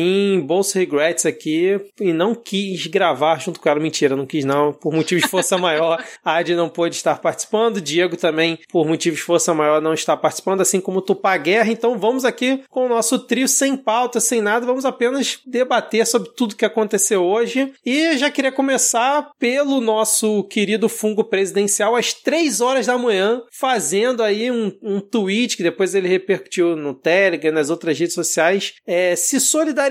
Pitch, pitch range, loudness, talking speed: 200 Hz, 170-240 Hz, -18 LUFS, 185 wpm